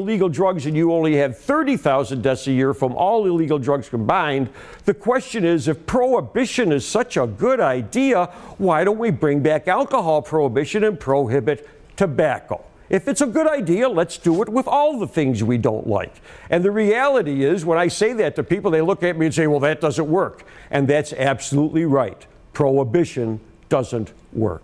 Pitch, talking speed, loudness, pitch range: 160 Hz, 190 wpm, -19 LUFS, 140-200 Hz